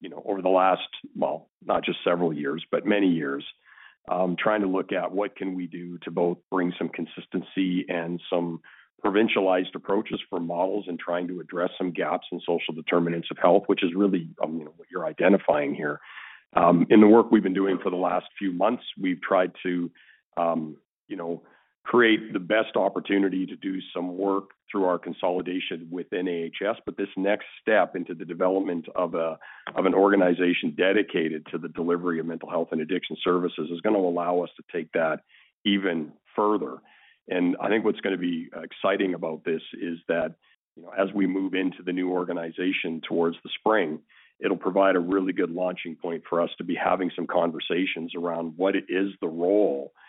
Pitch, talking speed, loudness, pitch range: 90 Hz, 195 wpm, -26 LUFS, 85-95 Hz